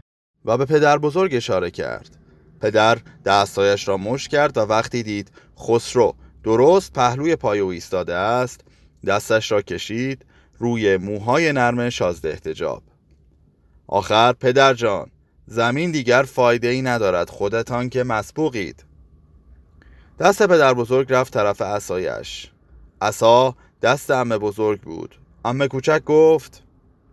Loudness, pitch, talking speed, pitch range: -19 LUFS, 120 Hz, 120 wpm, 100-130 Hz